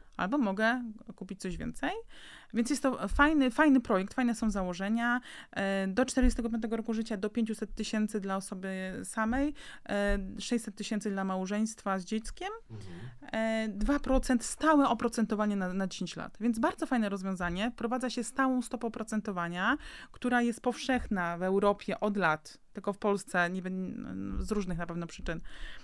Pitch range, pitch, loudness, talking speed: 195-245 Hz, 220 Hz, -32 LUFS, 145 wpm